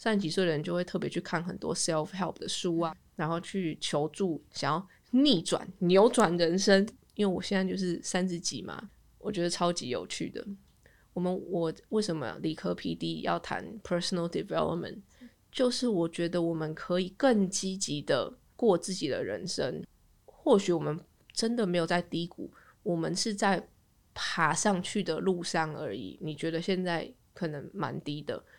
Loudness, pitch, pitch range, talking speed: -31 LUFS, 175 Hz, 165-195 Hz, 295 characters per minute